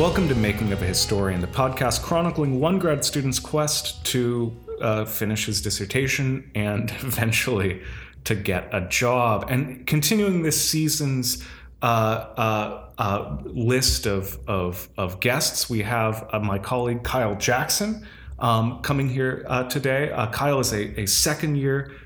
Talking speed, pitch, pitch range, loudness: 150 wpm, 125 Hz, 105-140 Hz, -23 LUFS